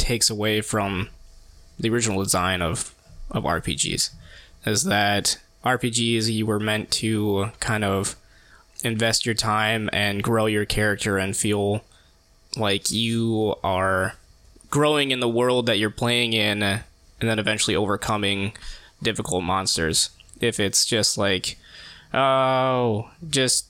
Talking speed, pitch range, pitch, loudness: 125 wpm, 100-115 Hz, 105 Hz, -22 LUFS